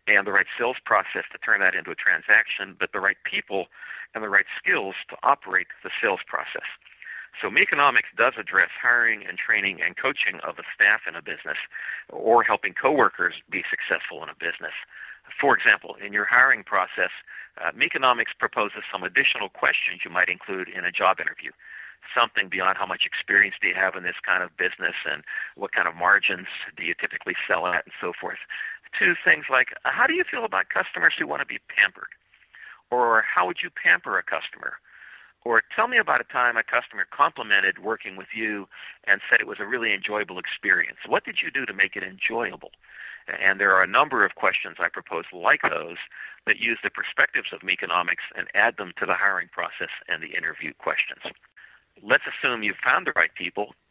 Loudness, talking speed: -23 LUFS, 195 wpm